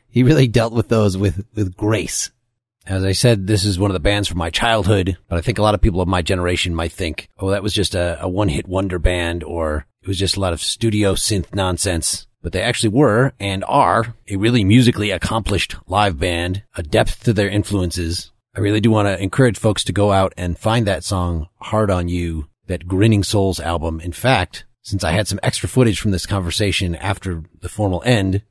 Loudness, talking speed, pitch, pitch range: -18 LUFS, 215 wpm, 100 Hz, 90-110 Hz